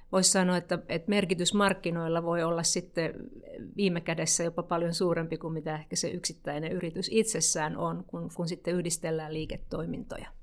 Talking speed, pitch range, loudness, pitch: 155 wpm, 160-180 Hz, -30 LUFS, 170 Hz